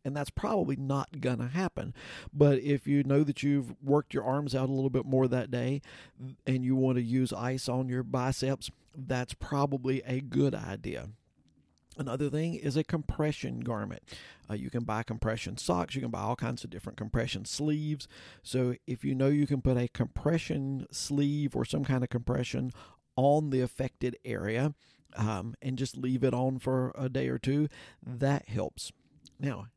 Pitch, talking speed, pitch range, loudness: 130 Hz, 185 wpm, 120-140 Hz, -32 LUFS